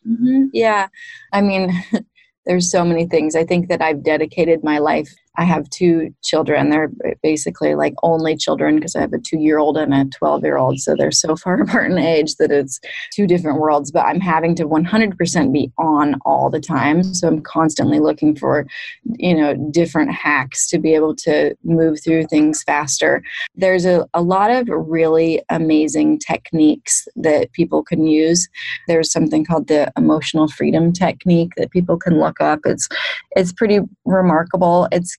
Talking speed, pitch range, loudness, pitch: 170 wpm, 155-185 Hz, -16 LUFS, 165 Hz